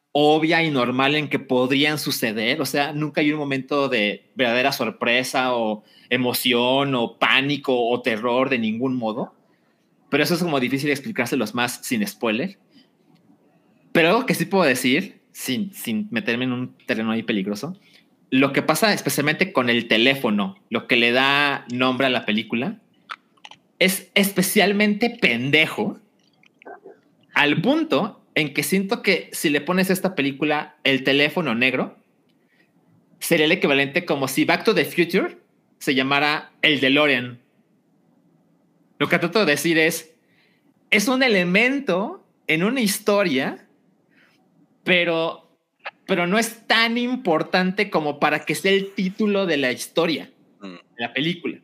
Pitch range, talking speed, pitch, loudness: 130-190 Hz, 145 wpm, 150 Hz, -20 LUFS